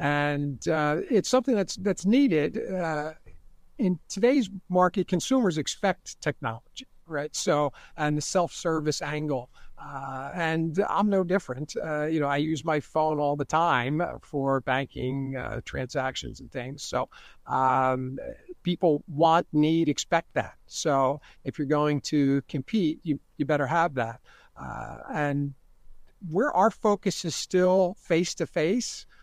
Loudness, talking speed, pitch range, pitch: -27 LUFS, 140 wpm, 140-180 Hz, 155 Hz